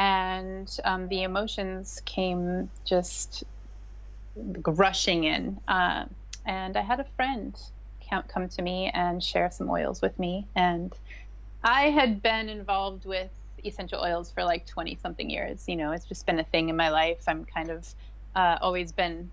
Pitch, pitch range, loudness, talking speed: 180 Hz, 165-195 Hz, -28 LUFS, 160 wpm